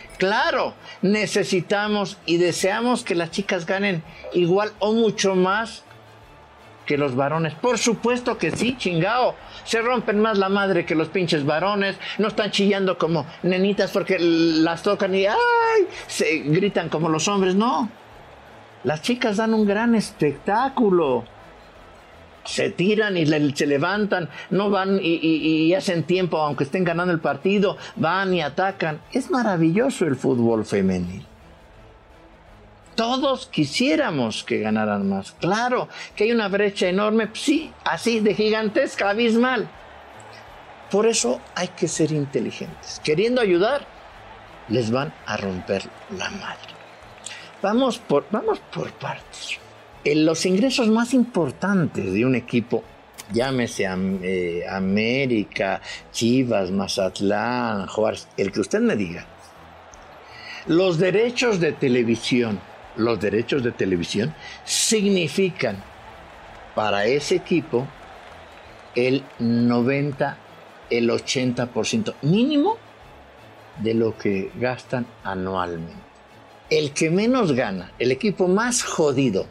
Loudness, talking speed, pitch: -22 LUFS, 120 wpm, 175 Hz